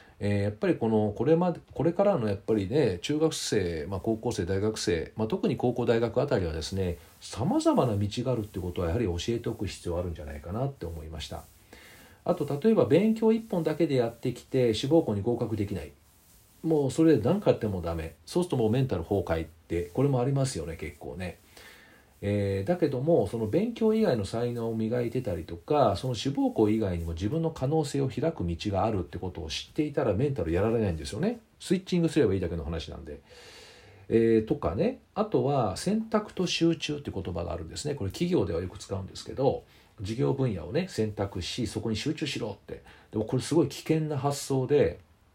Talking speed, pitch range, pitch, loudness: 410 characters per minute, 90-150 Hz, 115 Hz, -28 LUFS